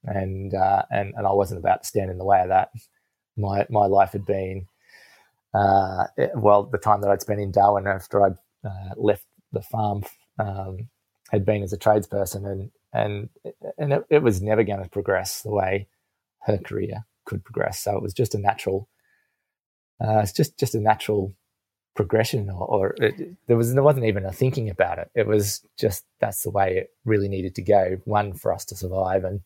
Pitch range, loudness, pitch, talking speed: 95-110 Hz, -23 LUFS, 100 Hz, 205 wpm